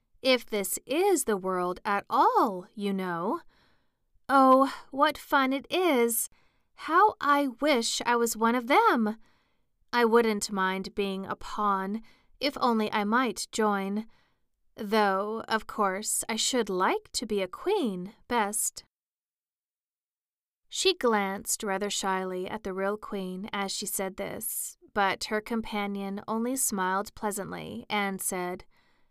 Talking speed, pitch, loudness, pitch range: 130 wpm, 215 Hz, -28 LUFS, 195-250 Hz